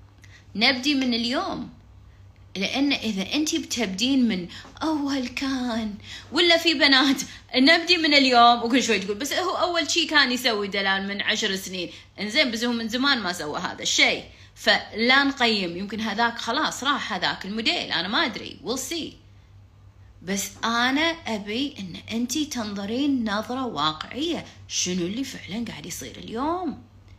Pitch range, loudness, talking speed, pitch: 195-280 Hz, -23 LUFS, 145 wpm, 235 Hz